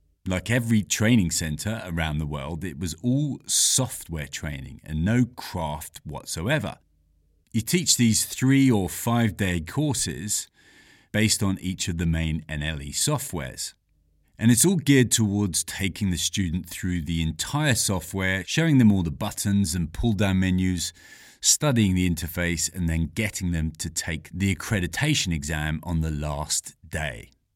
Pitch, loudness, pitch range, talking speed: 90 Hz, -24 LUFS, 80-110 Hz, 150 wpm